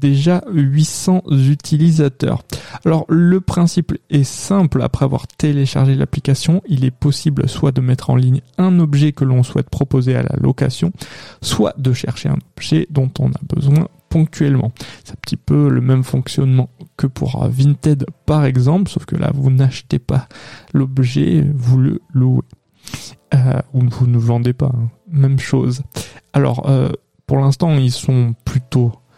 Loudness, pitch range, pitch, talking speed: -16 LUFS, 130-155 Hz, 140 Hz, 160 wpm